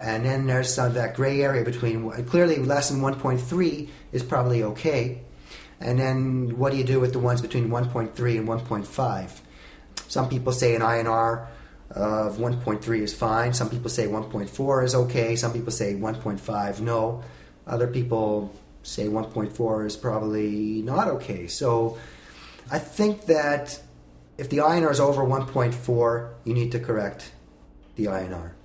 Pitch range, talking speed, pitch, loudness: 105-130 Hz, 155 wpm, 115 Hz, -25 LUFS